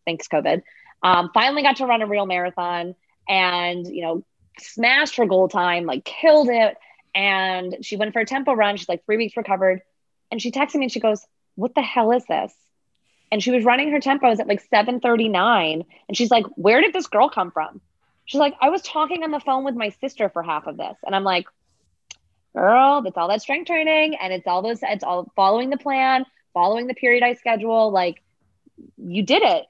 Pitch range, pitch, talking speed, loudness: 180-265 Hz, 220 Hz, 210 wpm, -20 LUFS